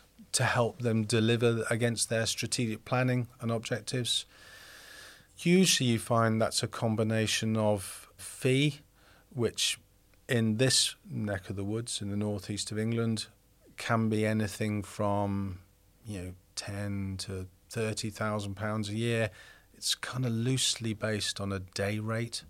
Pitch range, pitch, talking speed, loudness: 100-115 Hz, 110 Hz, 135 wpm, -30 LUFS